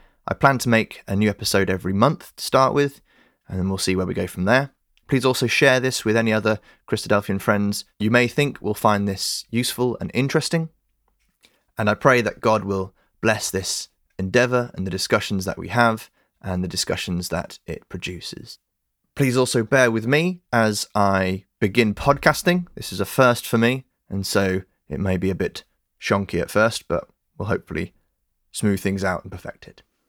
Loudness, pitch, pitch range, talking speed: -21 LUFS, 110 Hz, 95-125 Hz, 185 wpm